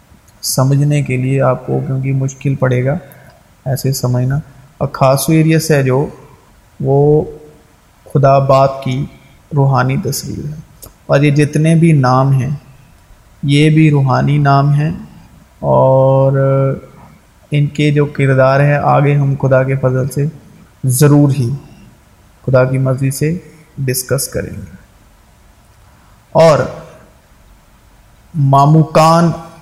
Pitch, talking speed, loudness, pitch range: 140 Hz, 115 wpm, -12 LUFS, 130-150 Hz